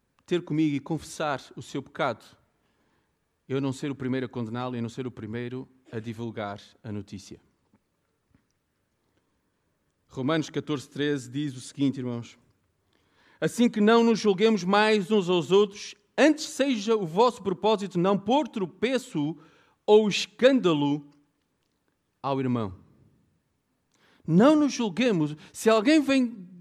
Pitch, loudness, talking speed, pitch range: 155 Hz, -26 LUFS, 130 wpm, 125-215 Hz